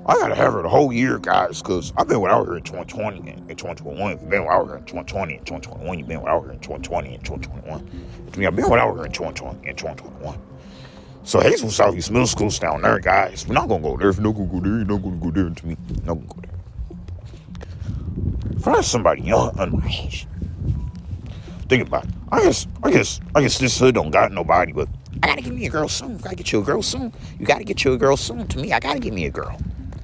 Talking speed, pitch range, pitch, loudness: 275 wpm, 75-100 Hz, 90 Hz, -21 LUFS